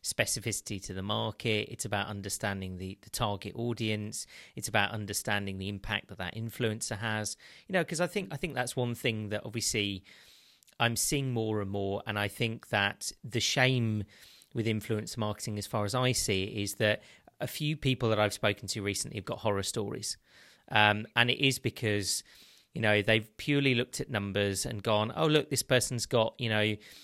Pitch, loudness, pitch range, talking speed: 110 Hz, -31 LUFS, 100-120 Hz, 190 wpm